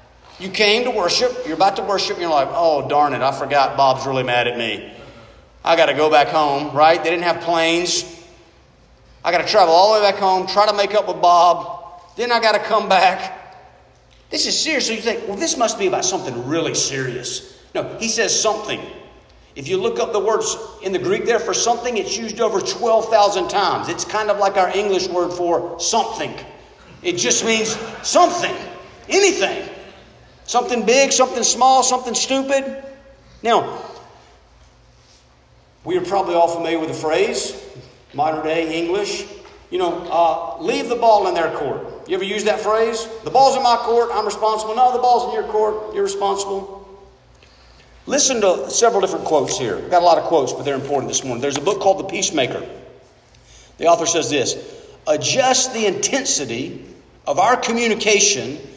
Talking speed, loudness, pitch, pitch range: 180 wpm, -18 LUFS, 210 Hz, 170-245 Hz